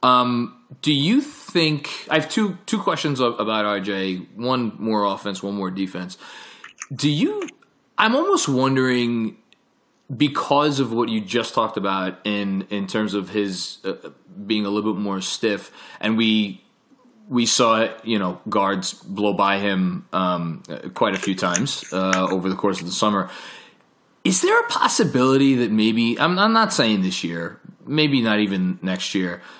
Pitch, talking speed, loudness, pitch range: 110 Hz, 165 wpm, -21 LUFS, 100-150 Hz